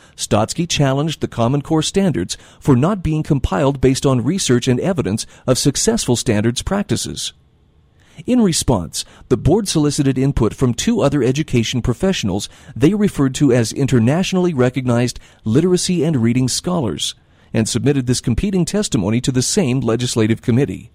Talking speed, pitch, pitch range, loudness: 145 wpm, 135 Hz, 120-155 Hz, -17 LUFS